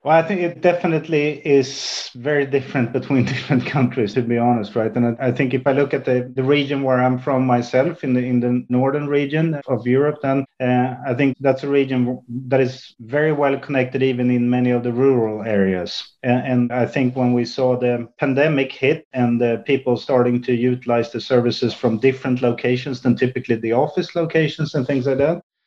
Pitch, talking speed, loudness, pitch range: 130 Hz, 200 wpm, -19 LUFS, 125-140 Hz